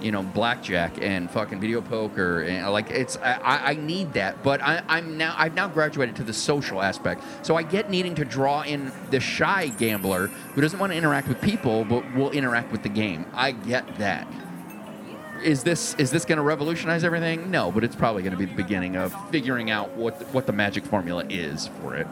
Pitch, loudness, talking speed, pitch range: 140 Hz, -25 LUFS, 215 wpm, 110-165 Hz